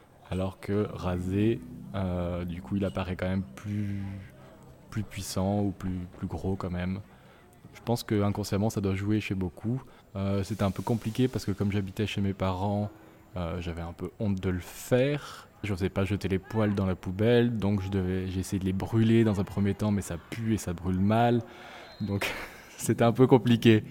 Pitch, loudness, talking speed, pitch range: 100 Hz, -29 LUFS, 200 wpm, 95-110 Hz